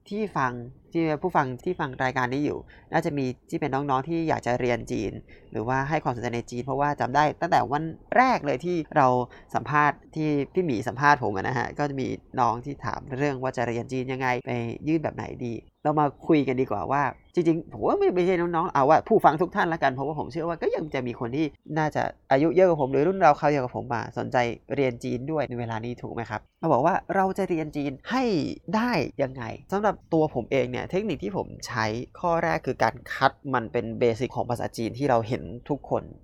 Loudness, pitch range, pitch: -26 LUFS, 120-160 Hz, 135 Hz